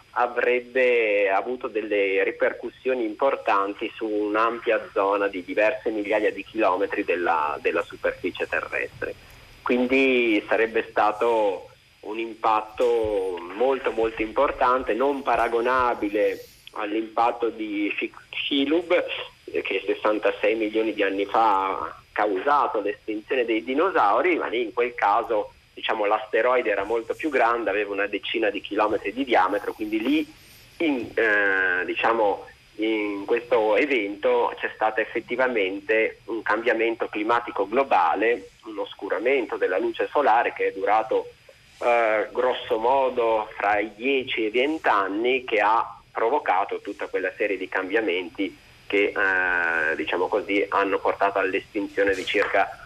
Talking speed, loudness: 125 wpm, -24 LUFS